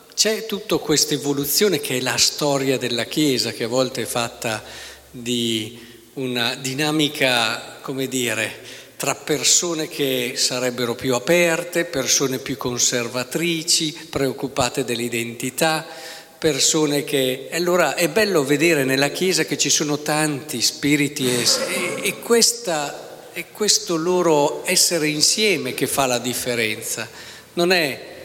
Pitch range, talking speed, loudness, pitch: 125-160 Hz, 125 wpm, -19 LUFS, 145 Hz